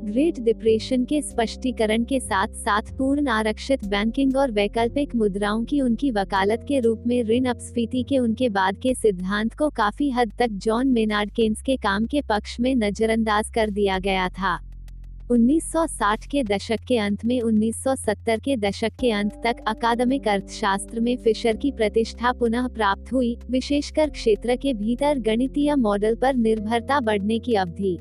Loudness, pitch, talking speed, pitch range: -23 LUFS, 230 Hz, 160 wpm, 215-255 Hz